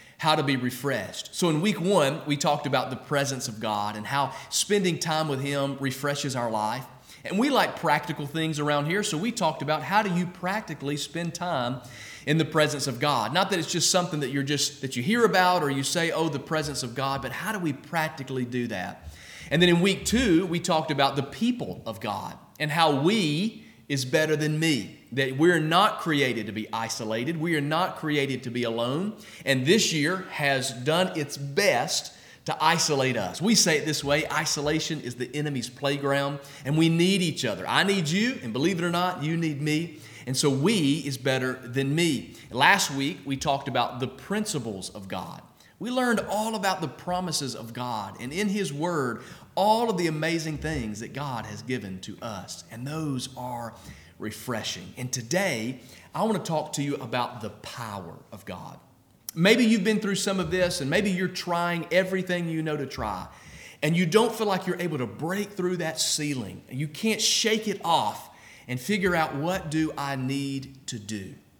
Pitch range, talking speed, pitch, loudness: 130-175 Hz, 200 wpm, 150 Hz, -26 LUFS